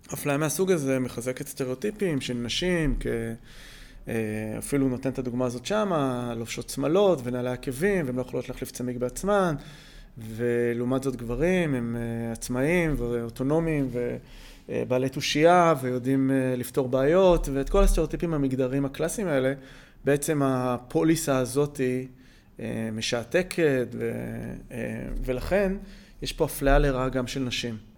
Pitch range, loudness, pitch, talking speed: 125-155 Hz, -26 LUFS, 135 Hz, 115 wpm